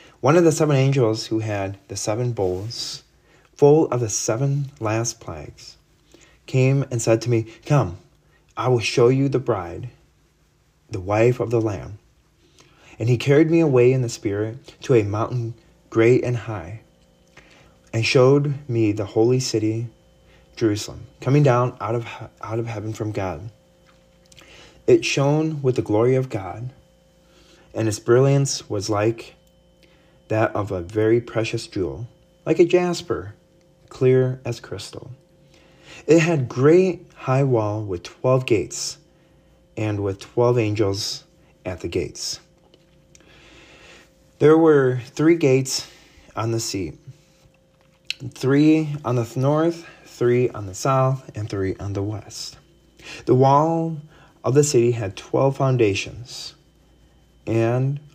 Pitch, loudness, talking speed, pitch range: 125 Hz, -21 LUFS, 135 wpm, 110-150 Hz